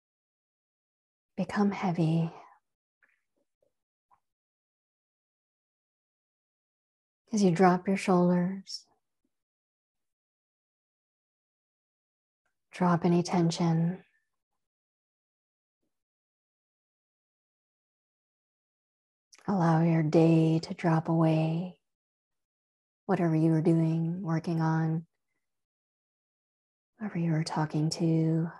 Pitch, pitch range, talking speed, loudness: 165 Hz, 160-180 Hz, 55 wpm, -28 LUFS